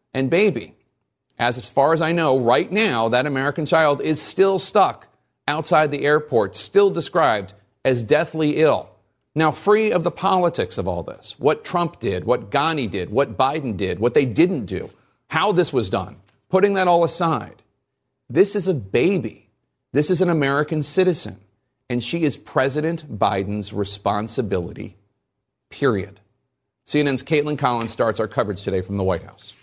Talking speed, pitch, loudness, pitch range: 160 wpm, 145 Hz, -20 LUFS, 115-165 Hz